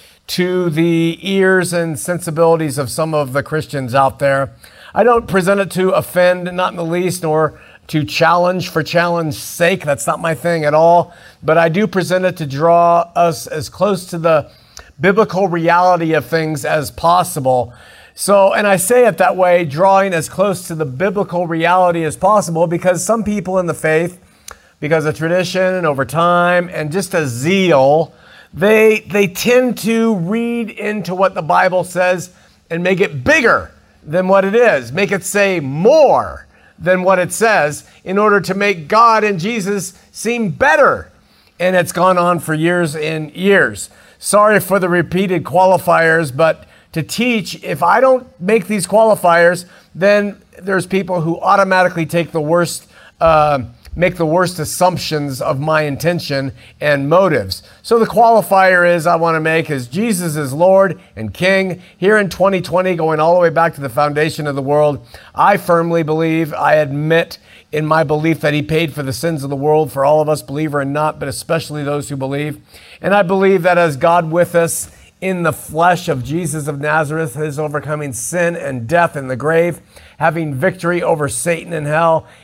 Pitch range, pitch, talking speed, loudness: 155-185 Hz, 170 Hz, 180 wpm, -14 LUFS